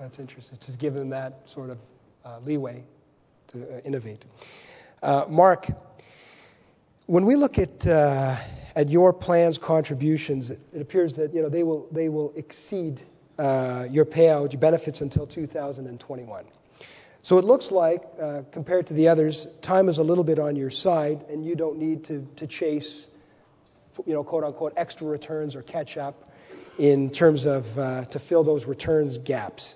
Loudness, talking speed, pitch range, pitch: -24 LUFS, 165 wpm, 140-160 Hz, 150 Hz